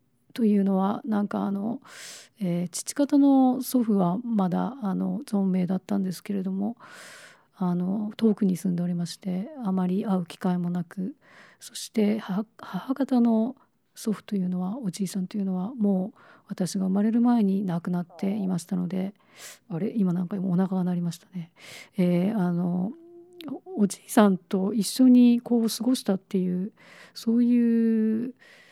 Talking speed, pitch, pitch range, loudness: 275 characters per minute, 200 Hz, 185-225 Hz, -26 LUFS